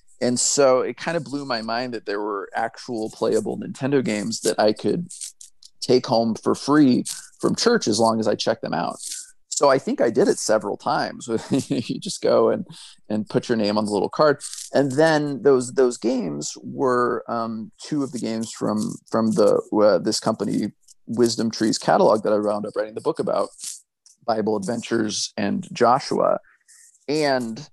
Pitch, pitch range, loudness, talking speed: 125 Hz, 110-160 Hz, -22 LUFS, 180 wpm